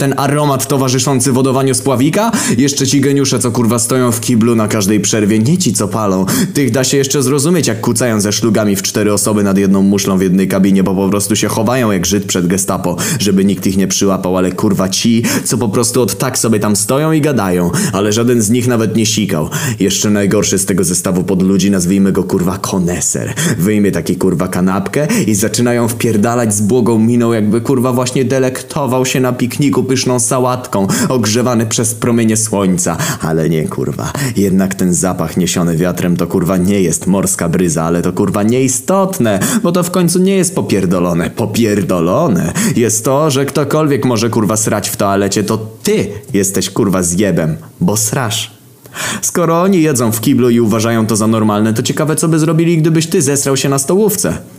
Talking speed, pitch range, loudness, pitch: 185 wpm, 100-135 Hz, -12 LUFS, 115 Hz